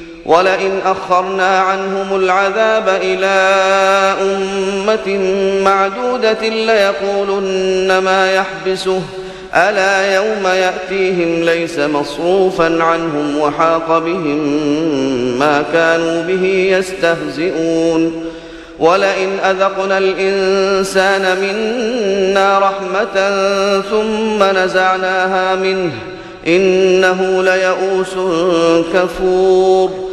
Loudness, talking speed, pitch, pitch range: -13 LUFS, 65 wpm, 190 Hz, 180-195 Hz